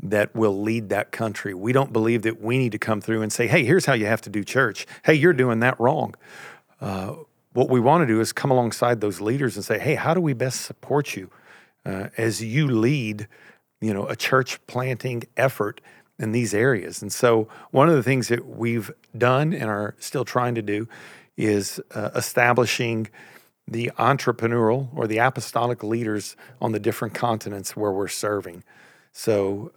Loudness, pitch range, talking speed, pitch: -23 LUFS, 110-130 Hz, 190 wpm, 115 Hz